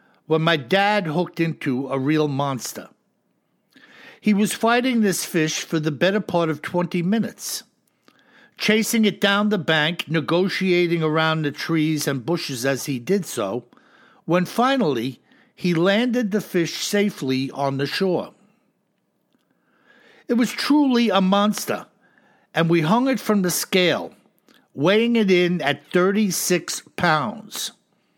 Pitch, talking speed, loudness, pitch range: 180 Hz, 135 wpm, -21 LUFS, 155-210 Hz